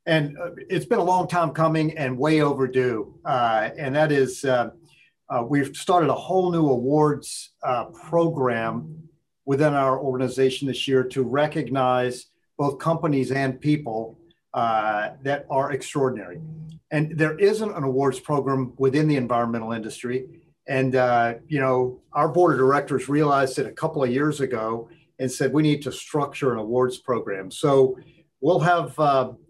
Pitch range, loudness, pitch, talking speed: 130-160 Hz, -23 LUFS, 140 Hz, 155 wpm